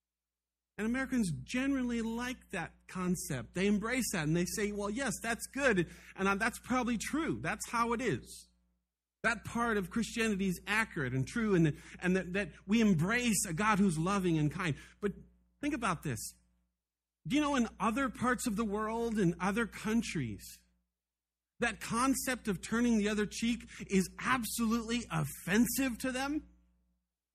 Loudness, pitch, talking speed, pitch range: -34 LUFS, 205 Hz, 160 wpm, 155-235 Hz